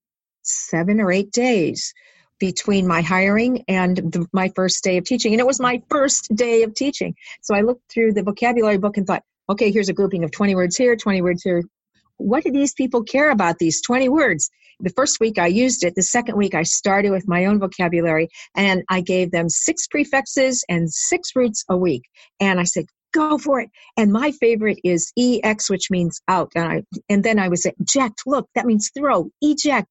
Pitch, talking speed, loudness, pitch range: 210 Hz, 210 wpm, -19 LUFS, 185-250 Hz